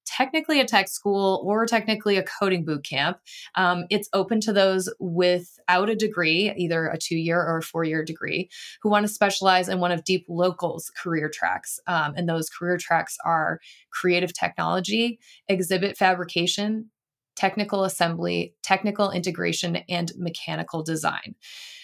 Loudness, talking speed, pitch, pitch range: -24 LUFS, 150 wpm, 185 Hz, 170-205 Hz